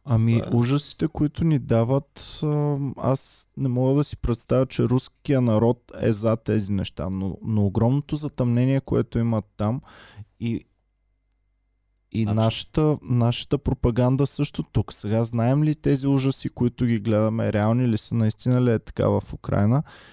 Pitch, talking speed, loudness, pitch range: 120 Hz, 145 wpm, -23 LUFS, 110-135 Hz